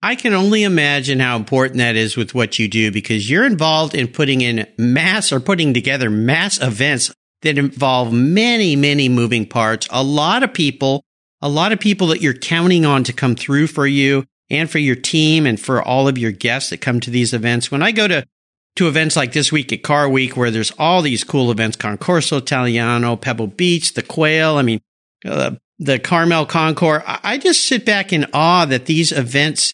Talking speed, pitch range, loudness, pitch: 205 wpm, 120-160 Hz, -15 LUFS, 140 Hz